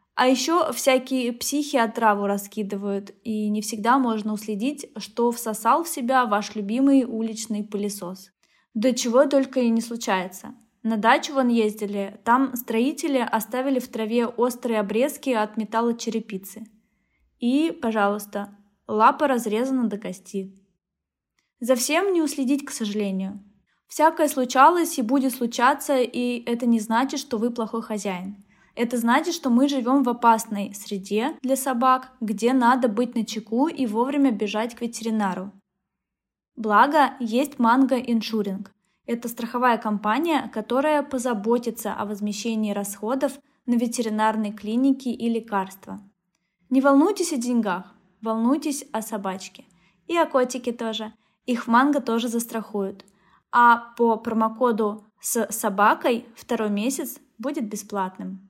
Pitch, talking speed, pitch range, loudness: 230 Hz, 130 wpm, 210-260 Hz, -23 LUFS